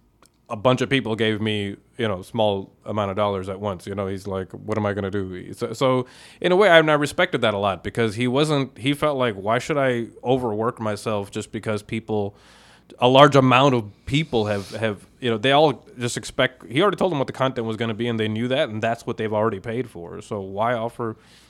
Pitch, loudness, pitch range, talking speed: 115 Hz, -22 LUFS, 105-125 Hz, 245 wpm